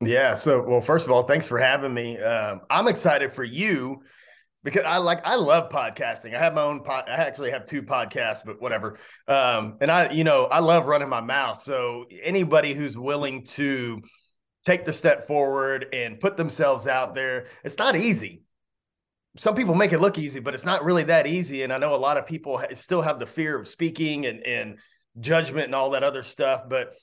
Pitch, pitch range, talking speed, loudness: 145 Hz, 130-165 Hz, 210 wpm, -23 LUFS